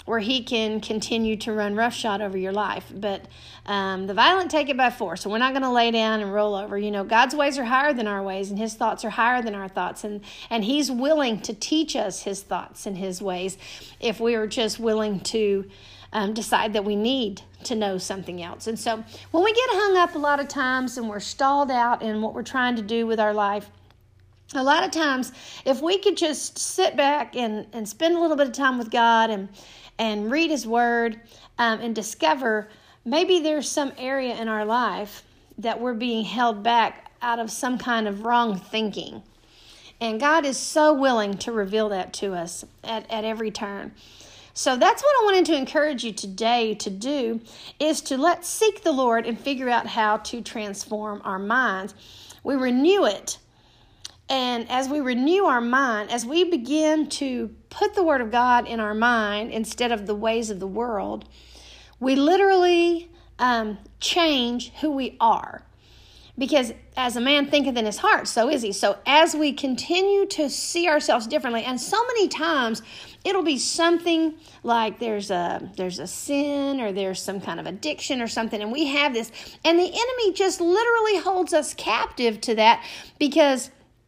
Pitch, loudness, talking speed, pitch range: 235 Hz, -23 LUFS, 195 wpm, 215-290 Hz